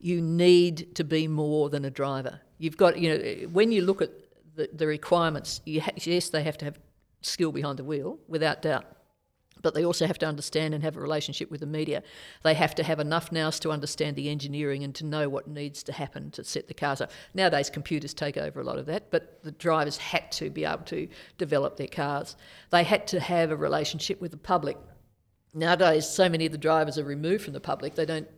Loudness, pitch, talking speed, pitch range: -28 LUFS, 155 Hz, 230 wpm, 150-170 Hz